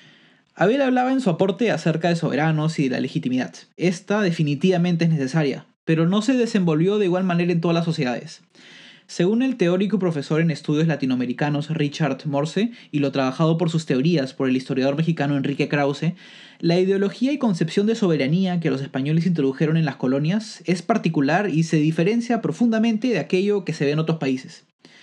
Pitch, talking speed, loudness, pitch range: 165 Hz, 180 wpm, -21 LUFS, 145-190 Hz